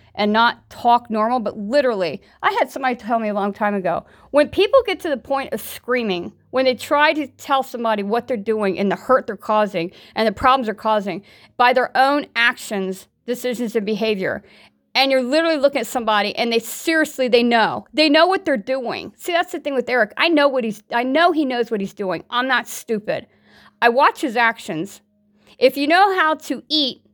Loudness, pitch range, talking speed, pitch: -19 LUFS, 215-280 Hz, 210 wpm, 245 Hz